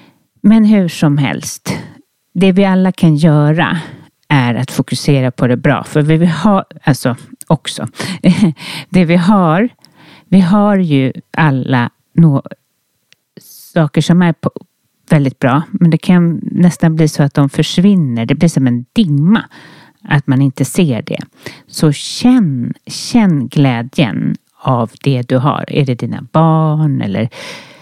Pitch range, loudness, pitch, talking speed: 140-180 Hz, -12 LUFS, 155 Hz, 140 wpm